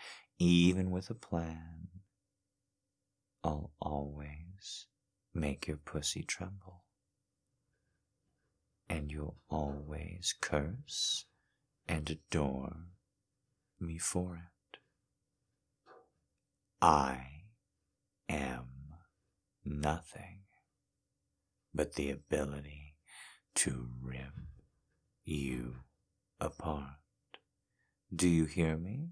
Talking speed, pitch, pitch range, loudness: 70 wpm, 80 Hz, 75-95 Hz, -37 LUFS